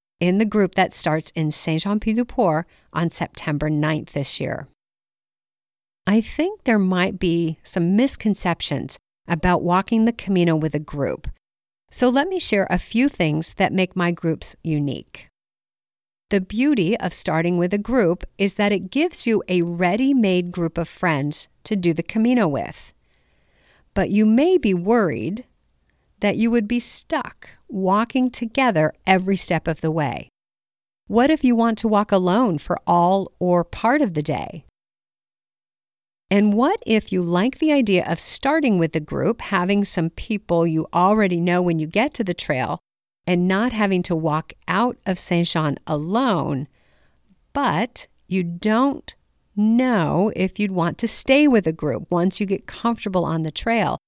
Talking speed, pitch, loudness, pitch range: 160 wpm, 185 Hz, -21 LUFS, 165-225 Hz